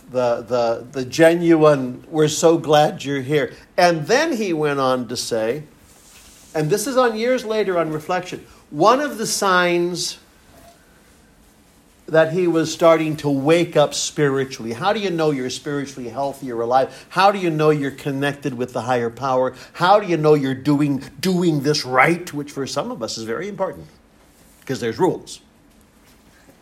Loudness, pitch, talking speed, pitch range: -19 LUFS, 150 Hz, 170 wpm, 130-170 Hz